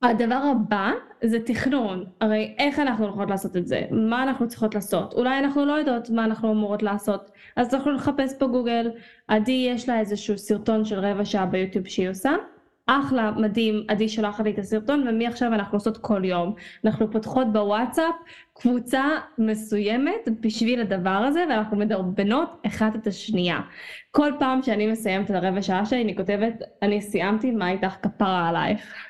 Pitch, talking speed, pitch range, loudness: 220 Hz, 165 wpm, 205-255 Hz, -24 LUFS